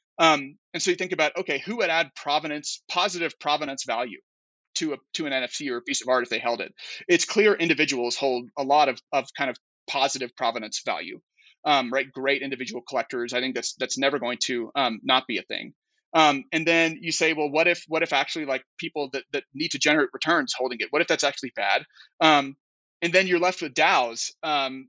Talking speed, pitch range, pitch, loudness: 220 wpm, 130-165 Hz, 150 Hz, -24 LUFS